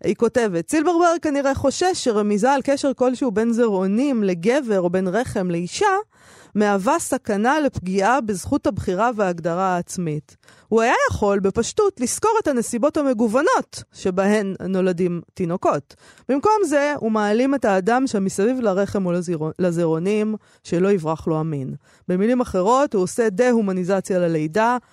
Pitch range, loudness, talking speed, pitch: 185-265 Hz, -20 LUFS, 130 wpm, 215 Hz